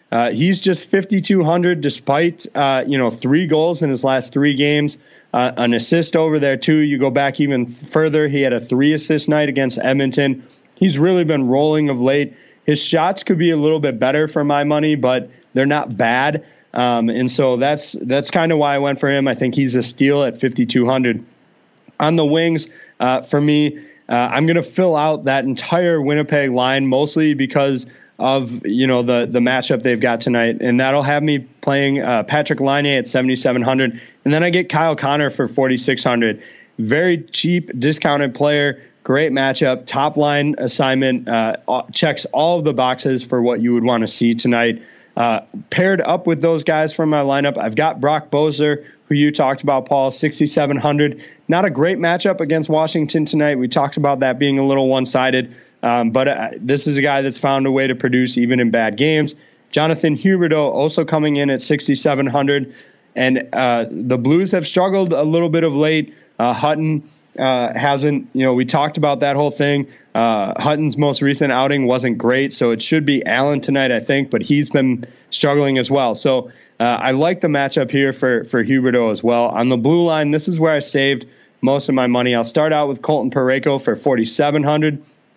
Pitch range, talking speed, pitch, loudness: 130-155 Hz, 195 wpm, 140 Hz, -16 LUFS